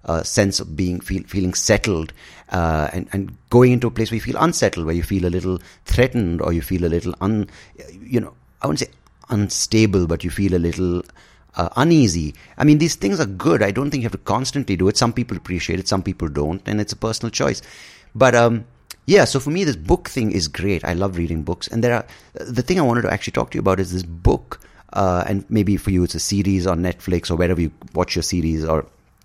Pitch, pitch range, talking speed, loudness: 95 Hz, 85-115 Hz, 240 wpm, -20 LUFS